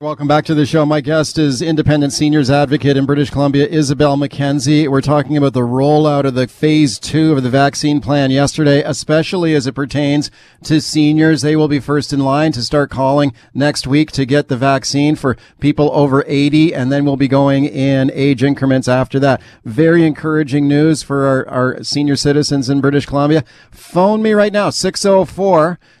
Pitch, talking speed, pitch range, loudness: 145 Hz, 190 wpm, 140-150 Hz, -13 LUFS